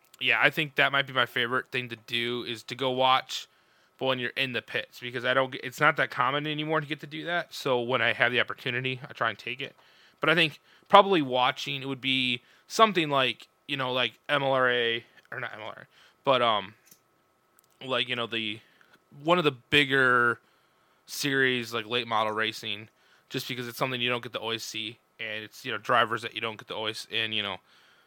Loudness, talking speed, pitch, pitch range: -27 LUFS, 215 wpm, 130 Hz, 120-140 Hz